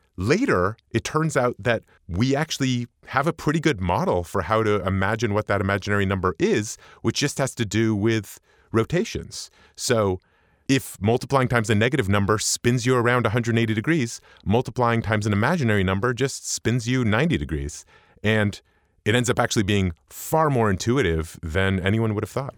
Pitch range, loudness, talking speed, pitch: 100-125 Hz, -23 LUFS, 170 wpm, 115 Hz